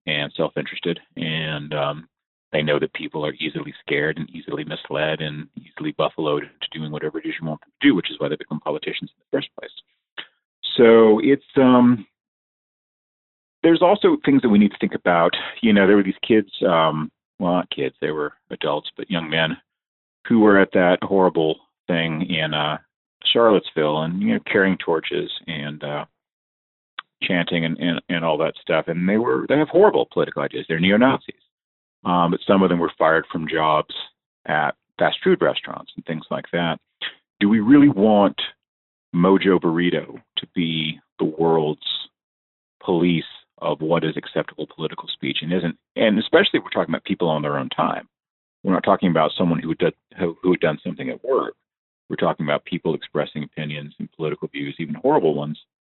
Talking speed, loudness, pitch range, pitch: 185 wpm, -20 LUFS, 75-95 Hz, 85 Hz